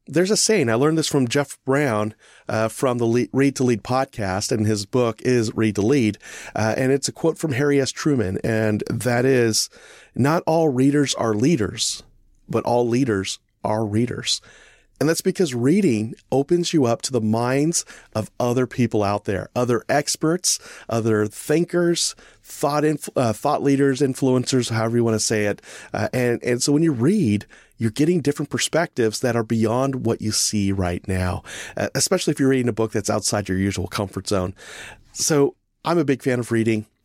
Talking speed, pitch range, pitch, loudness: 185 wpm, 110-145 Hz, 120 Hz, -21 LUFS